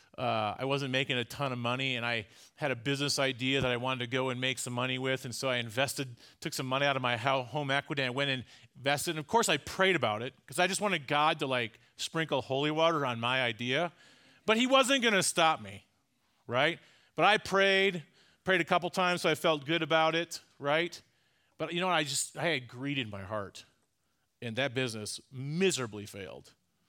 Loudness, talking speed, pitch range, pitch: -30 LUFS, 225 wpm, 125-165 Hz, 140 Hz